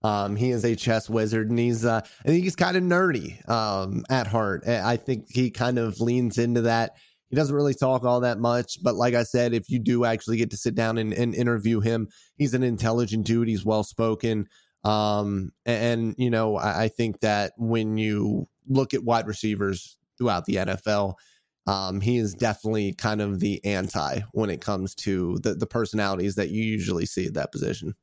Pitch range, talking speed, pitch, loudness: 105-120 Hz, 205 wpm, 115 Hz, -25 LUFS